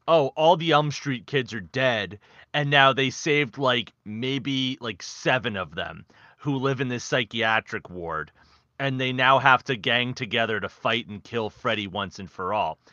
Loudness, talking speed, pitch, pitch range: -24 LUFS, 185 wpm, 130 Hz, 110-140 Hz